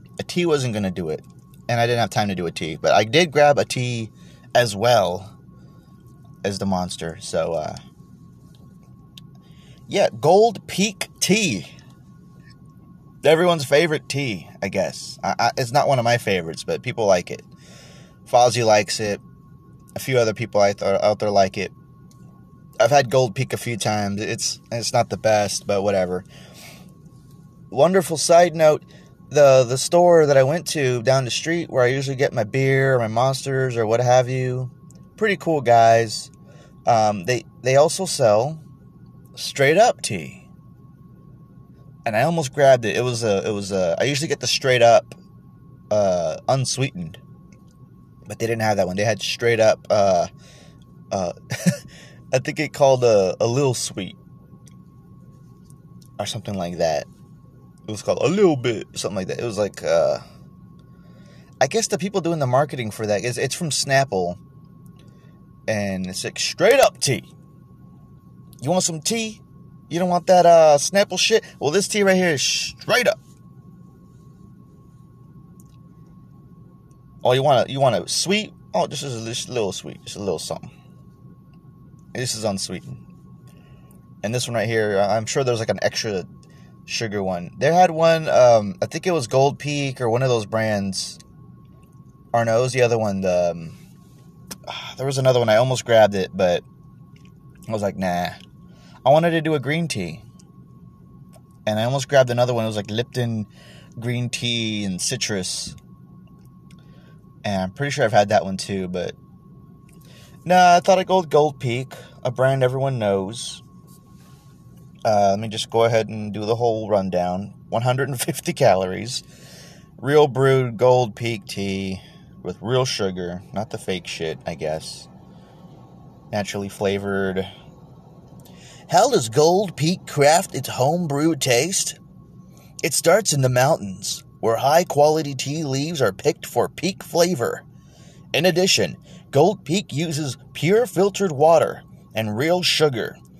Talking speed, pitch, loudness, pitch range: 160 wpm, 130 Hz, -20 LUFS, 110-155 Hz